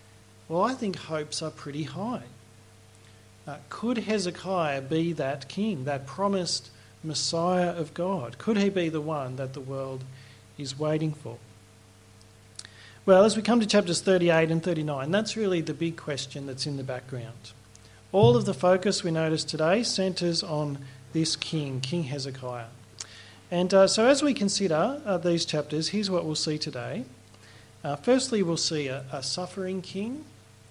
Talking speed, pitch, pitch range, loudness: 160 wpm, 155 Hz, 125-180 Hz, -27 LUFS